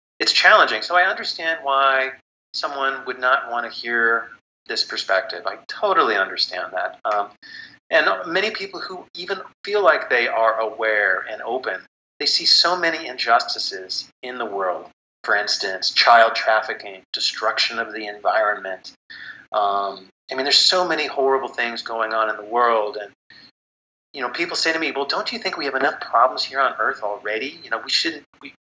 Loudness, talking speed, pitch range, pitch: -20 LUFS, 170 wpm, 105-135 Hz, 115 Hz